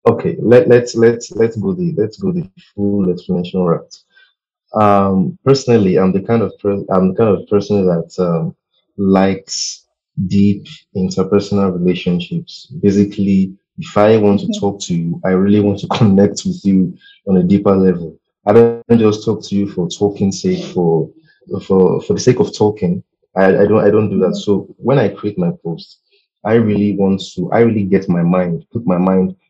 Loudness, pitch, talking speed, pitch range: -14 LUFS, 100 Hz, 185 wpm, 95-115 Hz